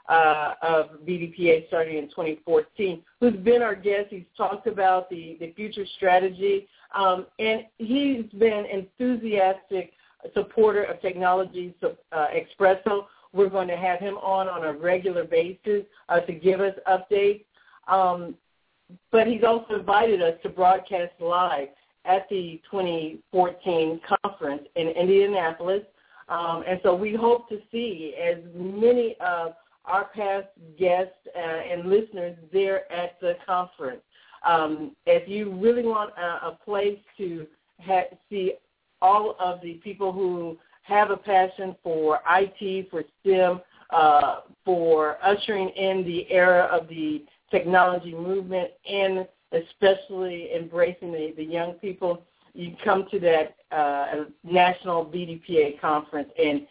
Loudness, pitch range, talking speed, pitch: -24 LUFS, 170-200 Hz, 135 wpm, 185 Hz